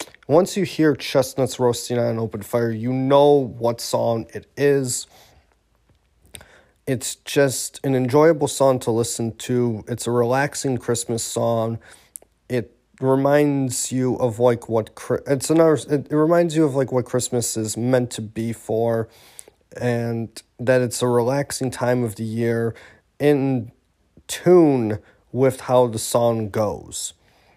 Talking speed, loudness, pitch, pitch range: 140 wpm, -21 LUFS, 125 Hz, 115-135 Hz